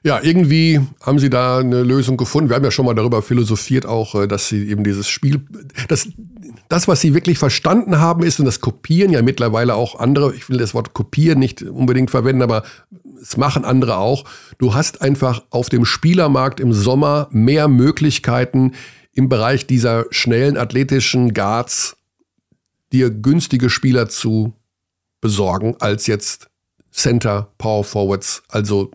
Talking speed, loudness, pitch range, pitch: 160 wpm, -16 LUFS, 115-140 Hz, 125 Hz